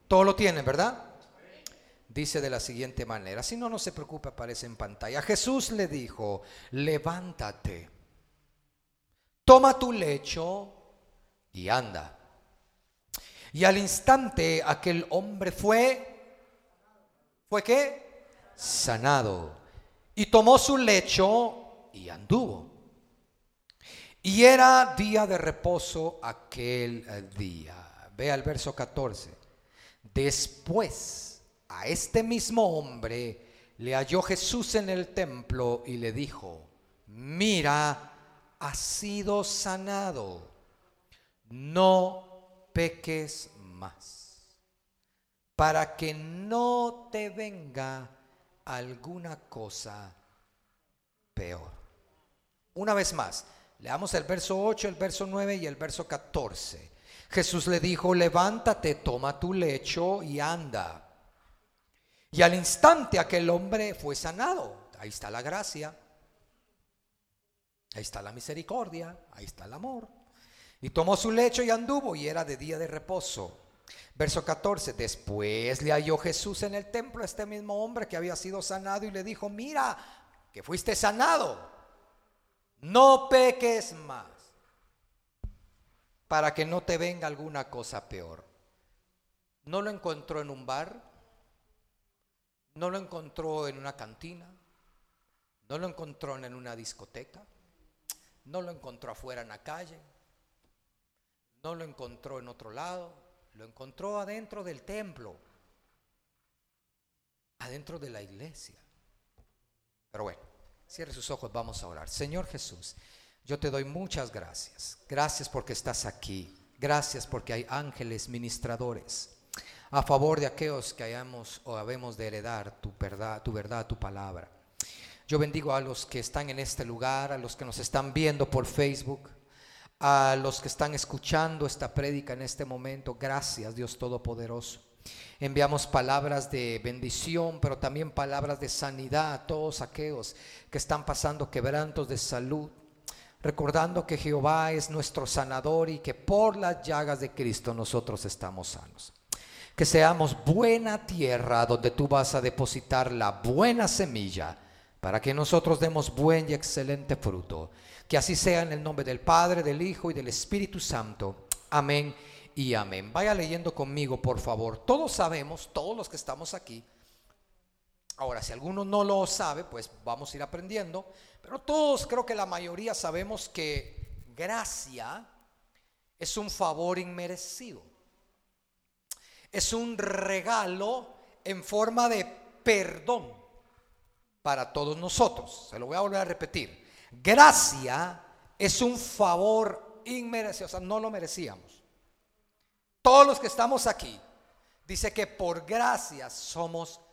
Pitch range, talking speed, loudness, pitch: 120-185 Hz, 130 wpm, -28 LUFS, 150 Hz